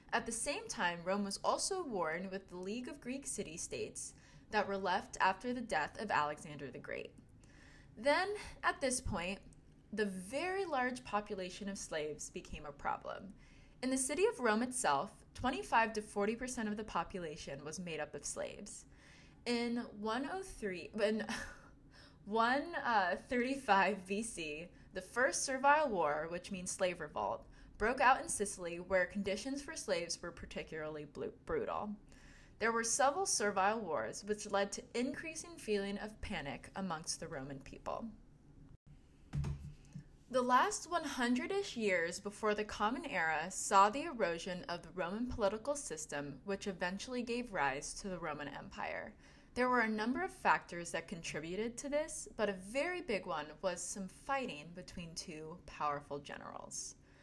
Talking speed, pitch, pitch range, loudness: 150 wpm, 205 Hz, 170-250 Hz, -38 LUFS